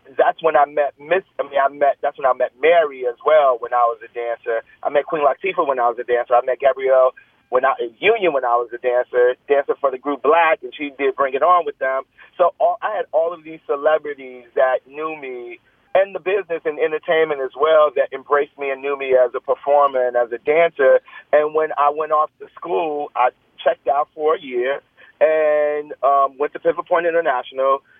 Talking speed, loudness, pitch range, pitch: 225 wpm, -19 LUFS, 130-170 Hz, 145 Hz